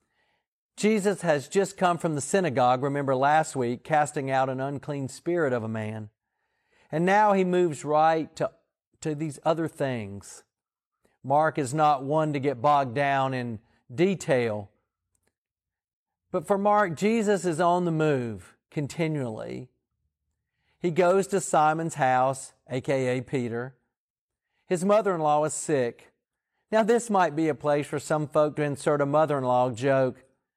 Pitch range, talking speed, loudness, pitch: 130-170 Hz, 150 wpm, -25 LUFS, 150 Hz